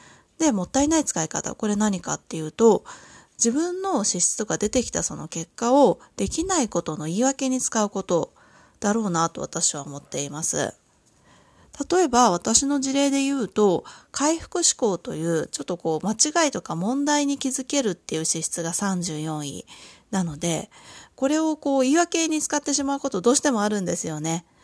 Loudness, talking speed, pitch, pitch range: -23 LUFS, 340 characters per minute, 225 Hz, 170-280 Hz